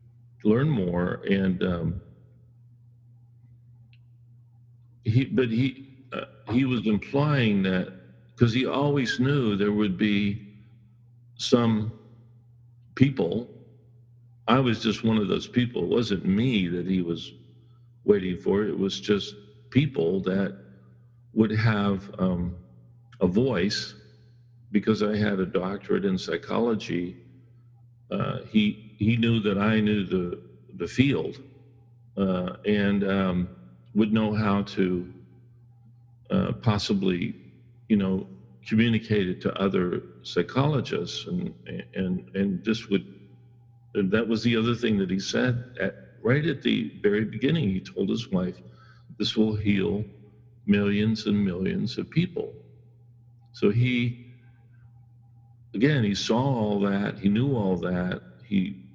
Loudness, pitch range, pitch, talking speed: -26 LUFS, 100-120 Hz, 110 Hz, 125 wpm